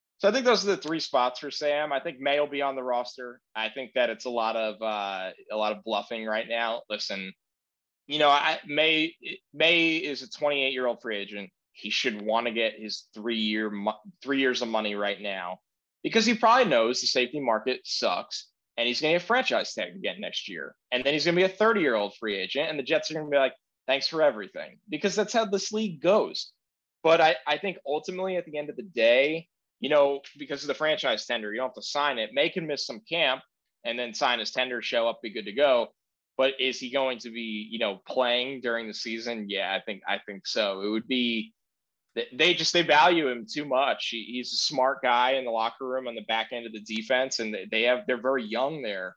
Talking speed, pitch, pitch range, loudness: 235 wpm, 125 Hz, 110-150 Hz, -27 LUFS